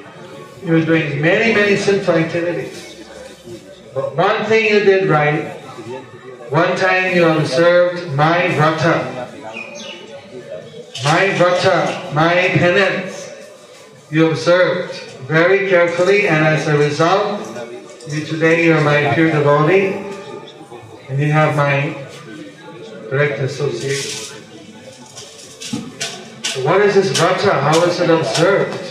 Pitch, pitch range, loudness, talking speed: 165 Hz, 150-185 Hz, -15 LUFS, 110 wpm